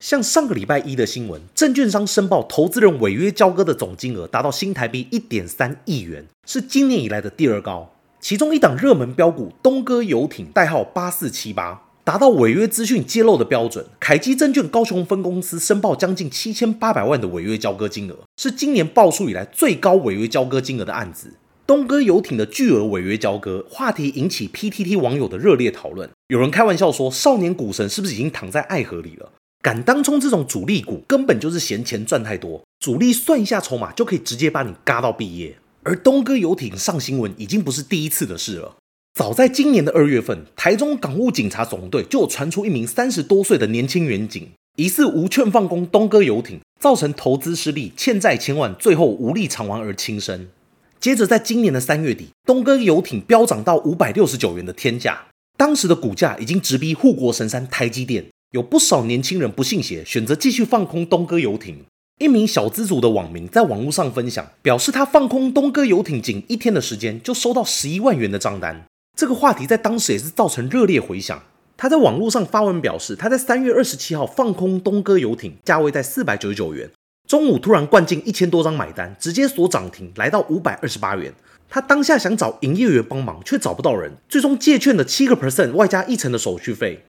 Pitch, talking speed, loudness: 195 Hz, 335 characters per minute, -18 LUFS